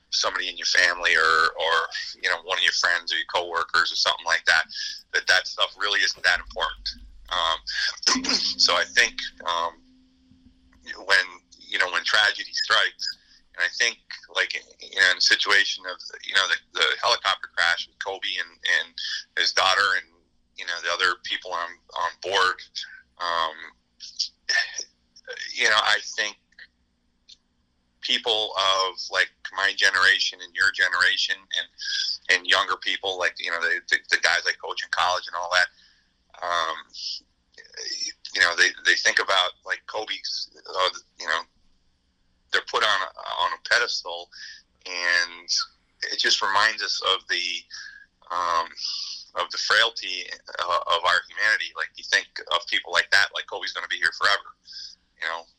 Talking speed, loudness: 160 wpm, -23 LUFS